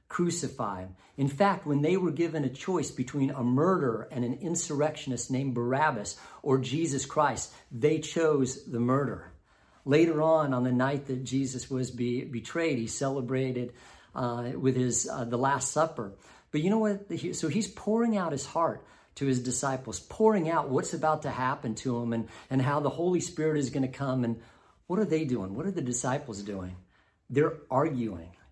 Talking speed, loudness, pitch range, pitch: 180 wpm, -29 LUFS, 120-155 Hz, 135 Hz